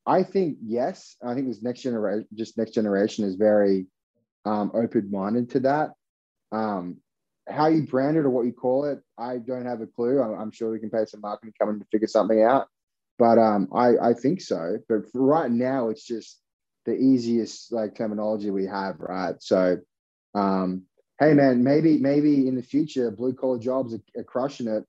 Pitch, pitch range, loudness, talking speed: 115 Hz, 105-130 Hz, -24 LUFS, 190 wpm